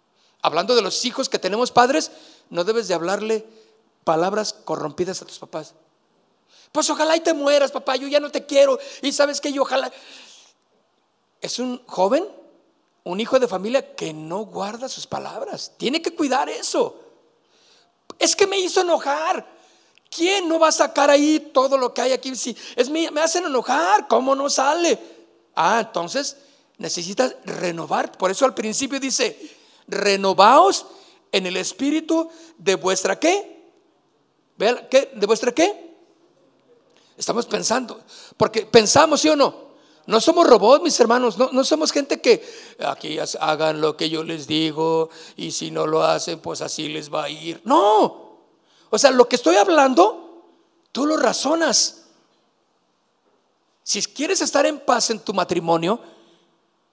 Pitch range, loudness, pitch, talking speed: 200-315 Hz, -19 LUFS, 265 Hz, 150 wpm